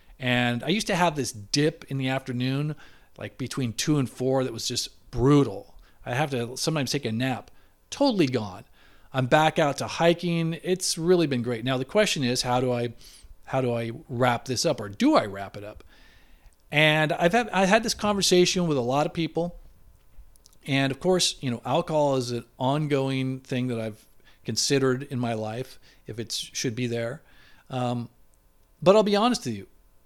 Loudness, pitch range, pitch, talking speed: -25 LUFS, 120-160 Hz, 130 Hz, 190 wpm